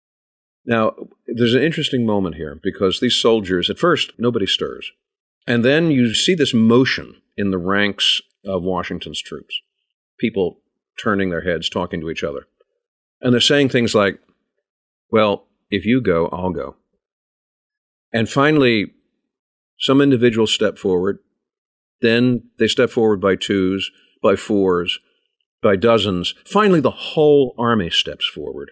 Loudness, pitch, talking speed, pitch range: -18 LUFS, 120 Hz, 140 wpm, 100-150 Hz